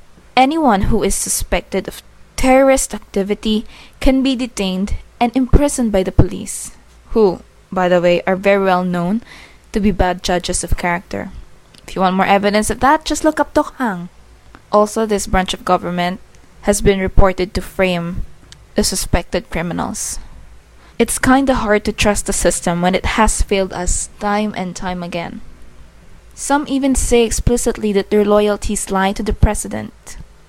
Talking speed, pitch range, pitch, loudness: 160 wpm, 185-230 Hz, 205 Hz, -16 LUFS